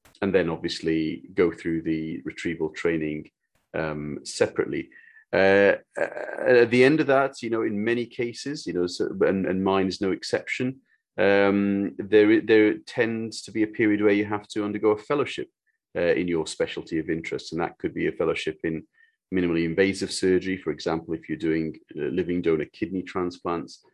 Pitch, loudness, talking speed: 105 Hz, -25 LUFS, 180 wpm